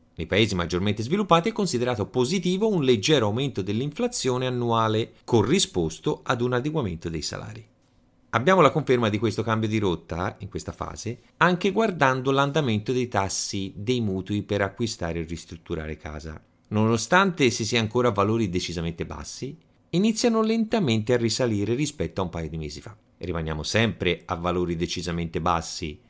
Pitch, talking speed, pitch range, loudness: 110 Hz, 155 wpm, 90-130 Hz, -24 LUFS